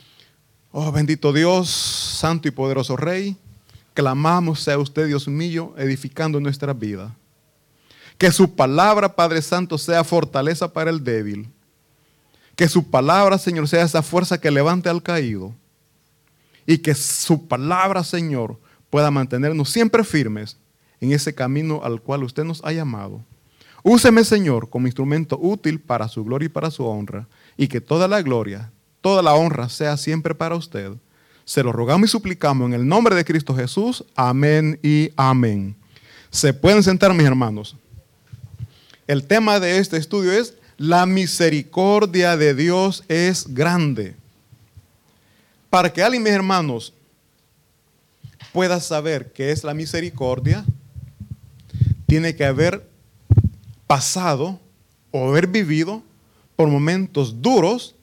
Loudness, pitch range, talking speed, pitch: -19 LUFS, 125-170 Hz, 135 wpm, 150 Hz